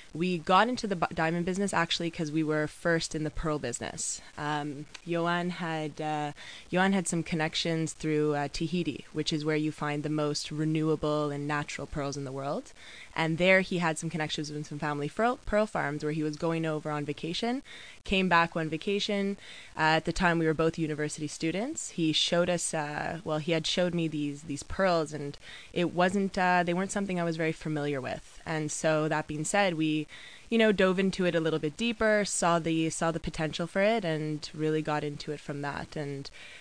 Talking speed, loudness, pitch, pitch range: 205 wpm, -30 LUFS, 160 Hz, 150-175 Hz